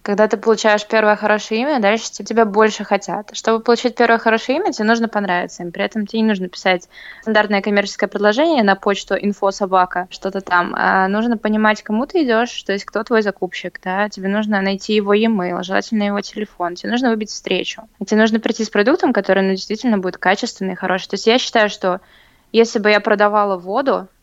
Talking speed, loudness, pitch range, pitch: 200 wpm, -17 LUFS, 195-225 Hz, 210 Hz